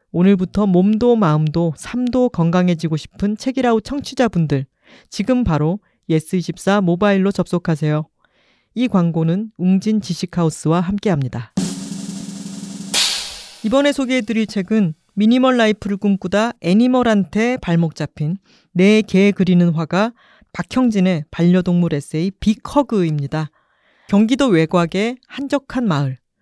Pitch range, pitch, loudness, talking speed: 170-220 Hz, 195 Hz, -17 LUFS, 280 characters per minute